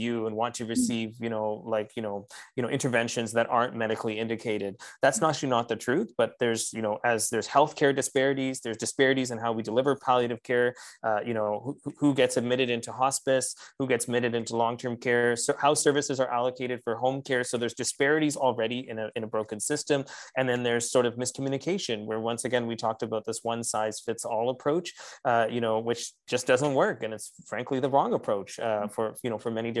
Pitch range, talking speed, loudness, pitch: 115-130 Hz, 215 wpm, -28 LUFS, 120 Hz